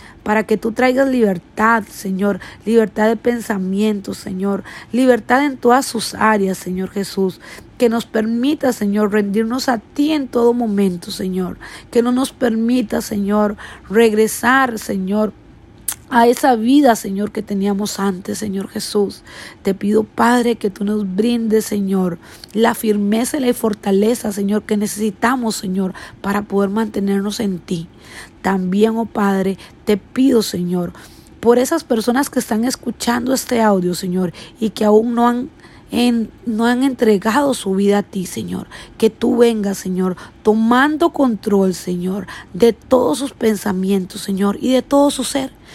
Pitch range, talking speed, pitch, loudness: 200-240 Hz, 145 wpm, 215 Hz, -17 LUFS